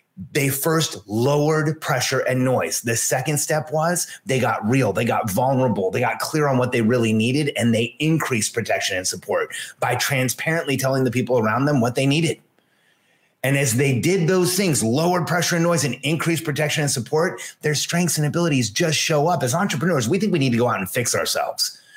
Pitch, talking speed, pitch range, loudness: 145 Hz, 200 wpm, 125-165 Hz, -20 LUFS